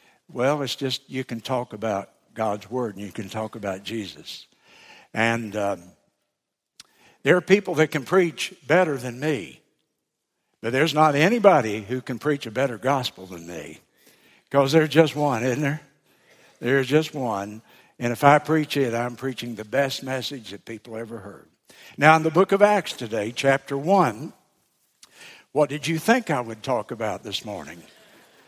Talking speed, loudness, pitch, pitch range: 170 wpm, -23 LUFS, 130 Hz, 115-150 Hz